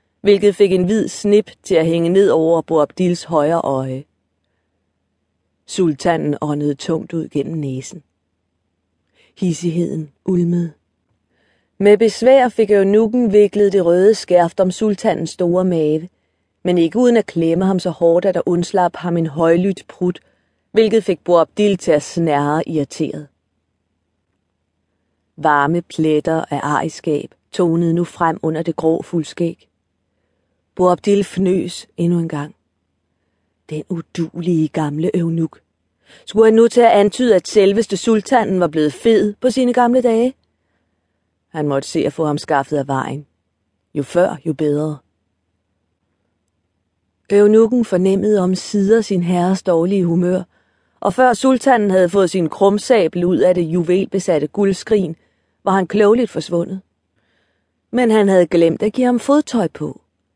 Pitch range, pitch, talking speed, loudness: 140-195 Hz, 170 Hz, 135 wpm, -16 LUFS